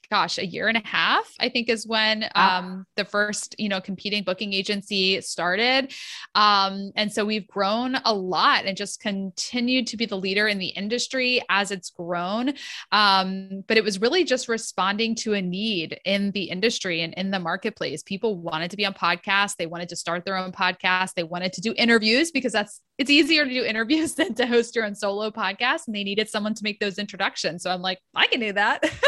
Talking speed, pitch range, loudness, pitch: 215 wpm, 190-230 Hz, -23 LUFS, 210 Hz